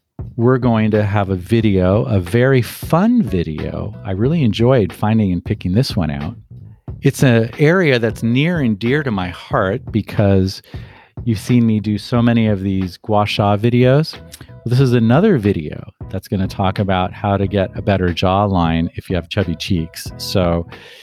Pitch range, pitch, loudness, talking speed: 95-125 Hz, 110 Hz, -16 LUFS, 180 wpm